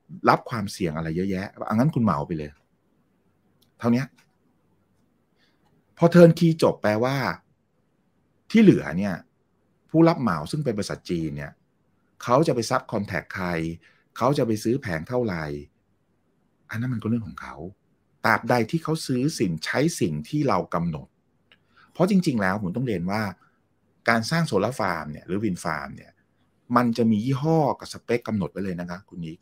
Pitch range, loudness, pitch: 85-130 Hz, -24 LUFS, 110 Hz